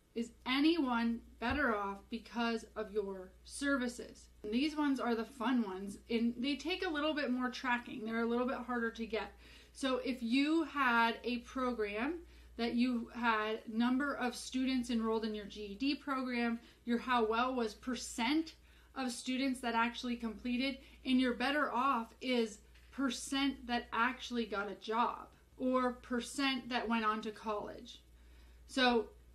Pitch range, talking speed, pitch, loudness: 225-260 Hz, 155 wpm, 240 Hz, -36 LUFS